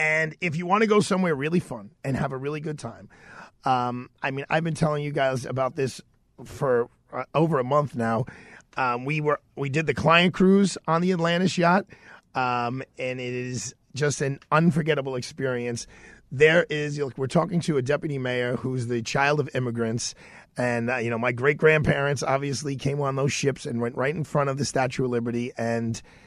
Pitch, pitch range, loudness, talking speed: 140 Hz, 125-155 Hz, -25 LUFS, 205 wpm